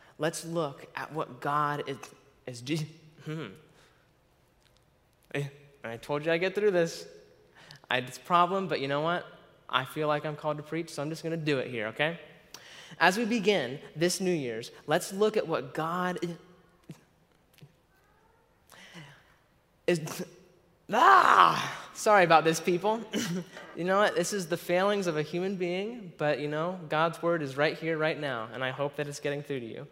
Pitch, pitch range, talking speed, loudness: 160 Hz, 145-180 Hz, 170 wpm, -29 LUFS